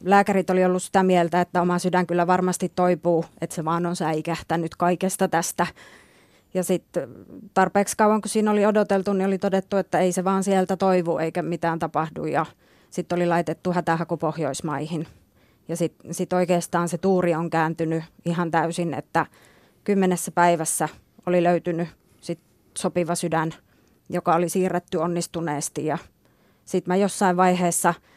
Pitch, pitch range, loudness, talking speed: 175 Hz, 165-185 Hz, -23 LUFS, 150 wpm